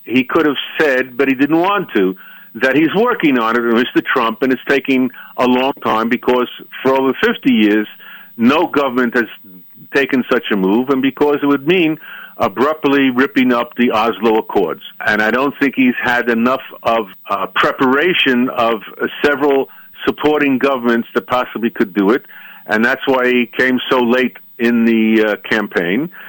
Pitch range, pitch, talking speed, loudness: 115-140 Hz, 130 Hz, 175 wpm, -15 LUFS